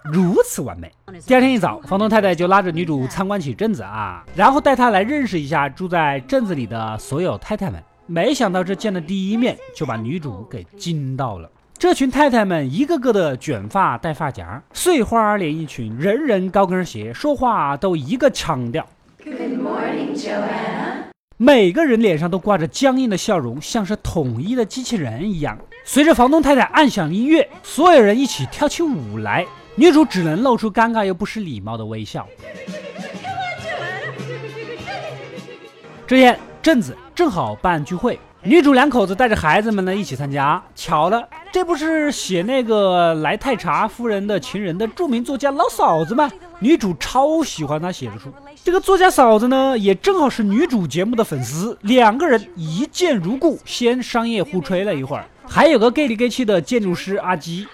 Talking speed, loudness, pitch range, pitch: 285 characters per minute, -18 LUFS, 165-260 Hz, 210 Hz